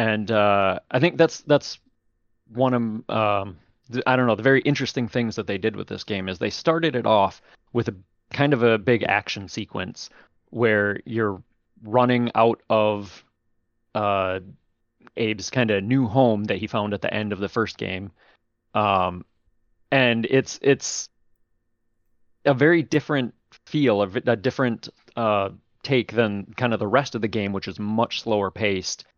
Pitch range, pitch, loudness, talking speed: 100-125 Hz, 115 Hz, -23 LUFS, 170 wpm